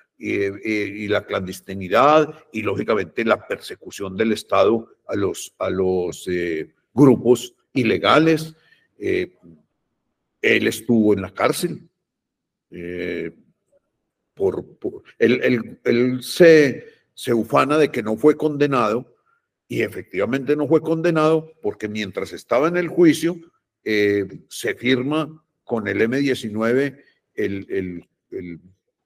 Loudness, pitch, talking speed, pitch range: -20 LUFS, 135 Hz, 115 wpm, 105-160 Hz